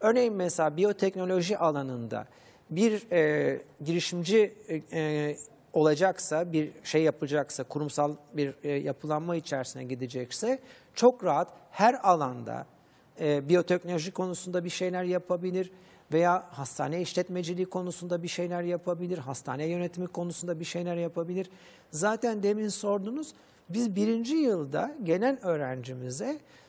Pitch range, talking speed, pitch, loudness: 150-185 Hz, 110 wpm, 175 Hz, -30 LUFS